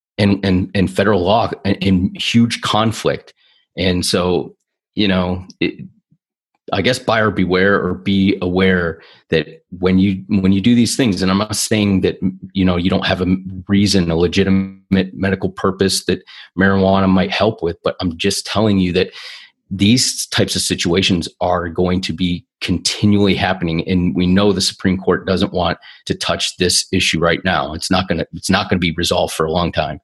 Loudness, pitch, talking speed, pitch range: -16 LUFS, 95 Hz, 185 wpm, 90-100 Hz